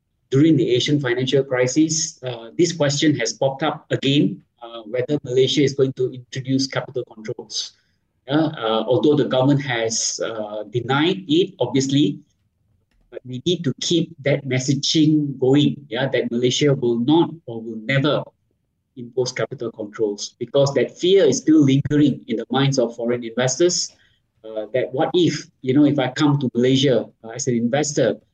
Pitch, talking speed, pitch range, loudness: 130 Hz, 165 wpm, 120-150 Hz, -20 LUFS